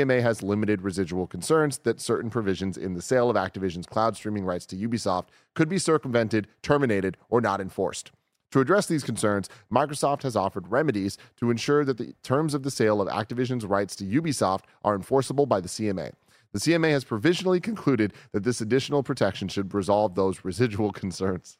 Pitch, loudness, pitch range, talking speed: 110 Hz, -26 LUFS, 100-135 Hz, 185 wpm